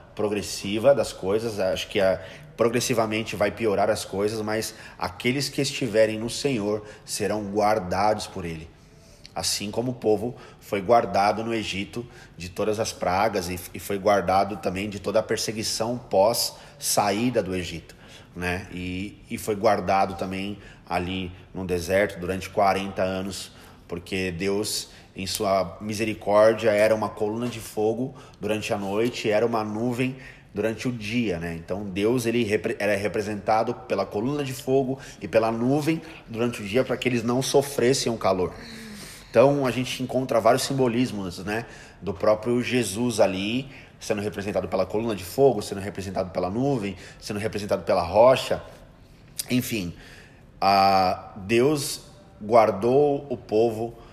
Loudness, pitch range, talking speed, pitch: -25 LUFS, 95-120 Hz, 145 wpm, 110 Hz